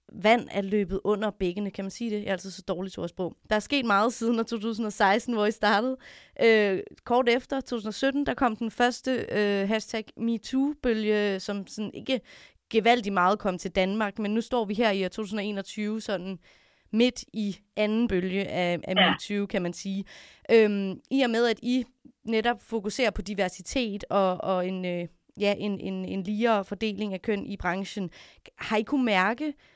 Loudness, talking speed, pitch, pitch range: -27 LUFS, 180 wpm, 210 Hz, 195-230 Hz